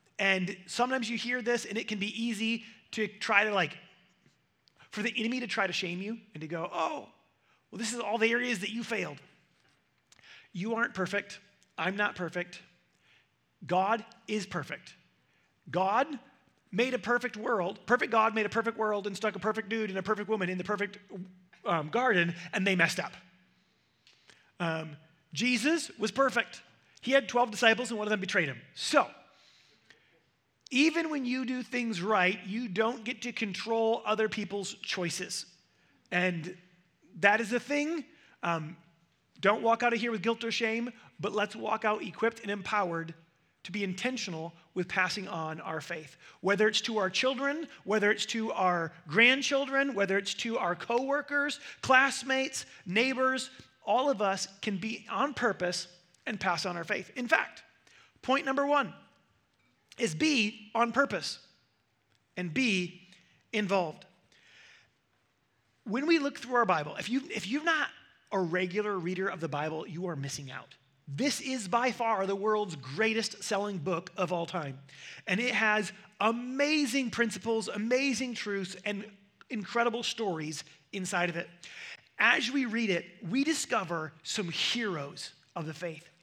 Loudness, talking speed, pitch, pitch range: -31 LUFS, 160 wpm, 210 Hz, 180-235 Hz